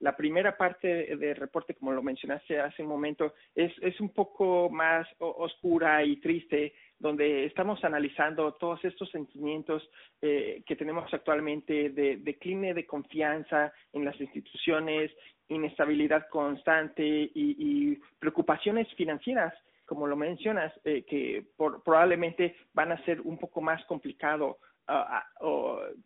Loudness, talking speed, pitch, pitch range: -30 LUFS, 135 wpm, 160 Hz, 150-175 Hz